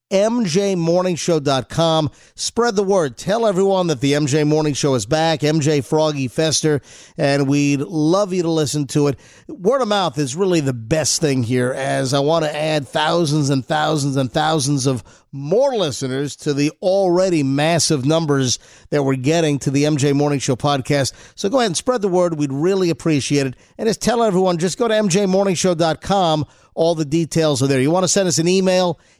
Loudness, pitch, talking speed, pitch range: -18 LUFS, 155 Hz, 190 wpm, 140-180 Hz